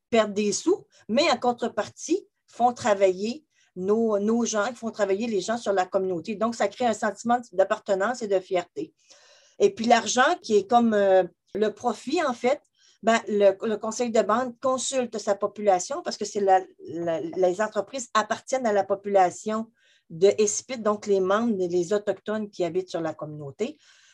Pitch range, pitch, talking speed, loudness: 195-240 Hz, 215 Hz, 170 wpm, -25 LUFS